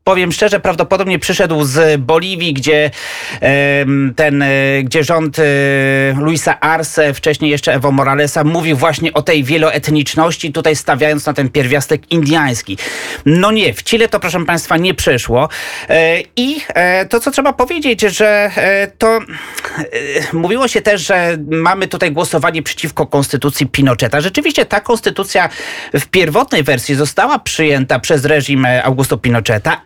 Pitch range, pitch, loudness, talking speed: 145-185 Hz, 160 Hz, -12 LUFS, 130 wpm